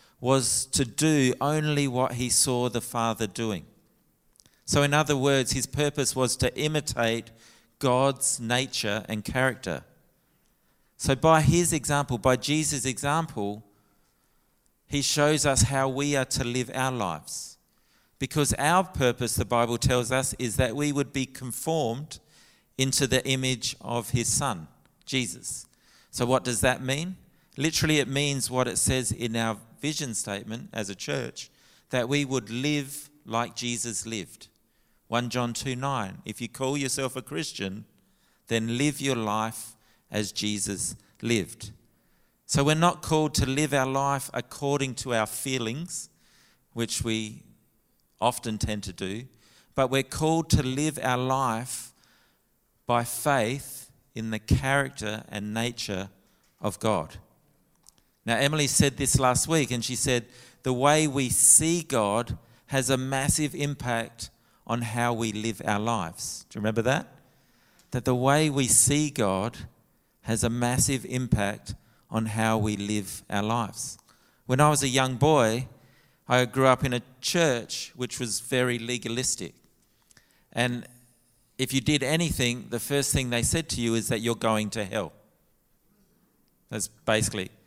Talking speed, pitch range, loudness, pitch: 150 wpm, 115-140 Hz, -26 LUFS, 125 Hz